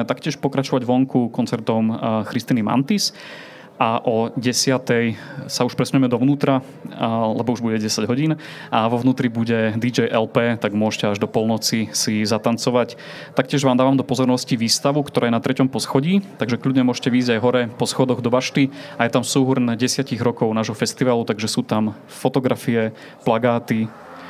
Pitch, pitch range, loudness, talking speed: 125 Hz, 115-135 Hz, -20 LUFS, 160 wpm